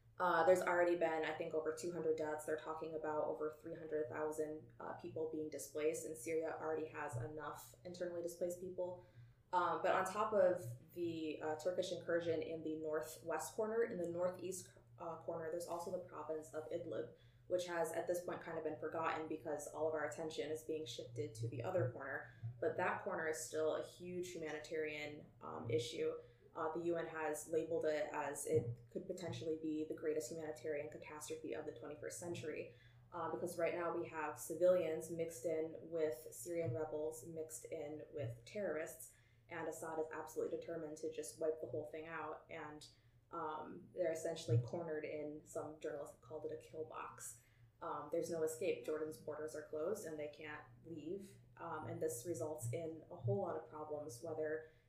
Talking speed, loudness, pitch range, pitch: 180 wpm, -43 LUFS, 150-165 Hz, 155 Hz